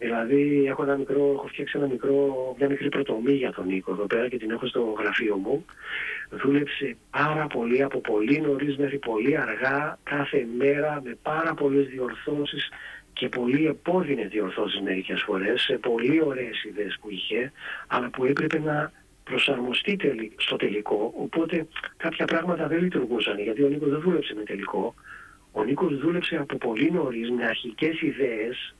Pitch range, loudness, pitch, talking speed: 125-150 Hz, -26 LUFS, 140 Hz, 165 wpm